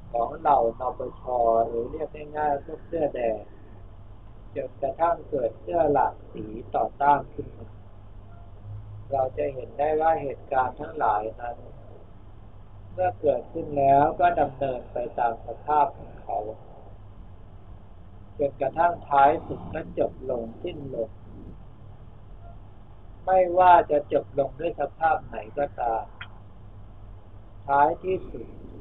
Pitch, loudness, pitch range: 115 Hz, -25 LUFS, 100-145 Hz